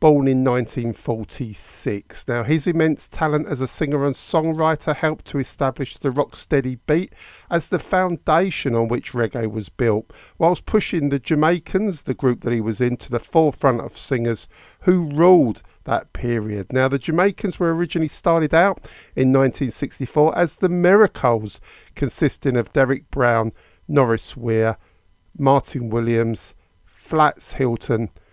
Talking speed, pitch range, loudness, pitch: 145 wpm, 115-160 Hz, -20 LUFS, 135 Hz